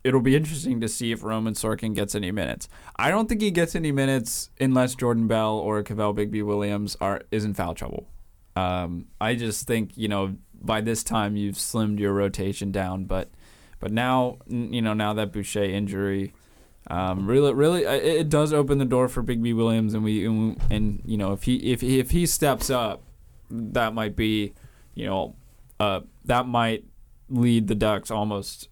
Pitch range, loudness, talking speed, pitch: 105-125 Hz, -25 LUFS, 190 wpm, 110 Hz